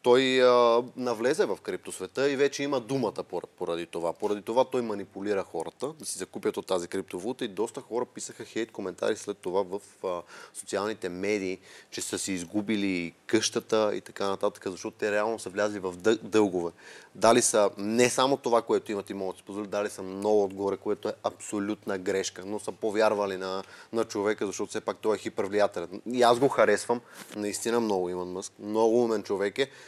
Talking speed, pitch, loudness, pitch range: 185 wpm, 105 Hz, -29 LUFS, 95-120 Hz